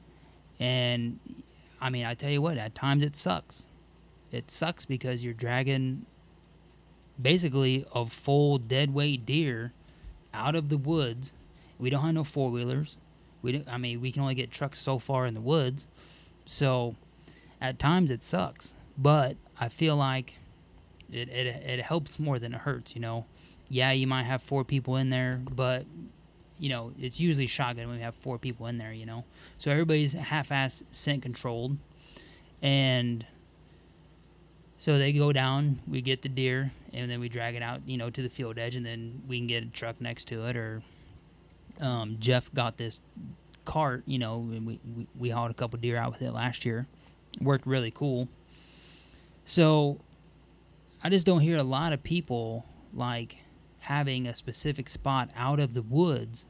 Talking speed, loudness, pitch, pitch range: 175 wpm, -30 LUFS, 130 Hz, 120-140 Hz